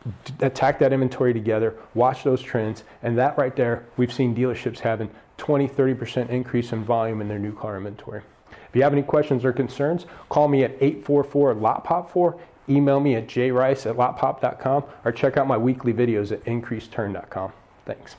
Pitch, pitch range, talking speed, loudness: 125 Hz, 115-140 Hz, 170 wpm, -23 LUFS